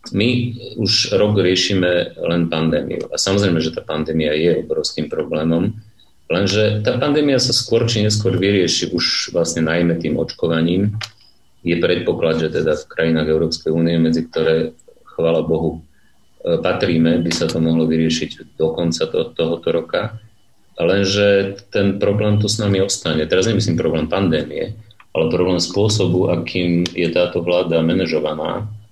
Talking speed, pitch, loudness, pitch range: 140 wpm, 90 Hz, -18 LUFS, 80-105 Hz